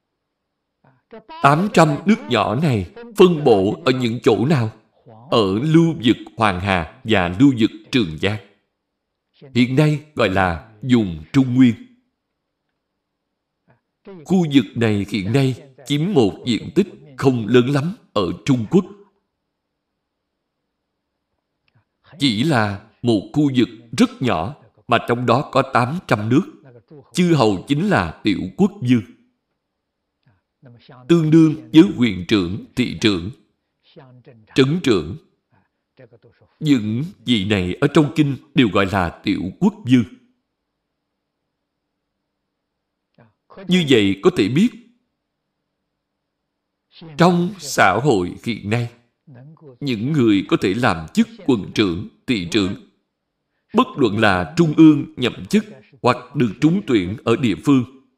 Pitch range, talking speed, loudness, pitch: 115-165 Hz, 120 wpm, -18 LUFS, 135 Hz